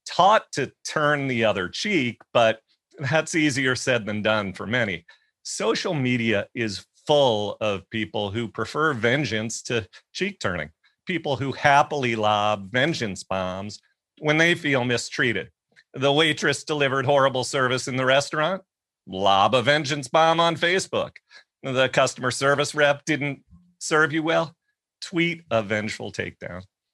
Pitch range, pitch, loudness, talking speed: 110-155 Hz, 135 Hz, -23 LUFS, 140 wpm